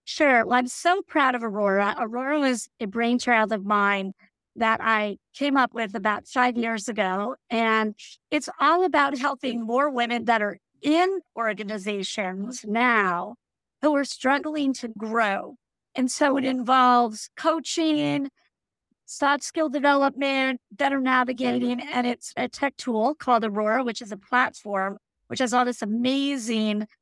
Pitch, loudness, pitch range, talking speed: 245 Hz, -24 LUFS, 220-280 Hz, 145 wpm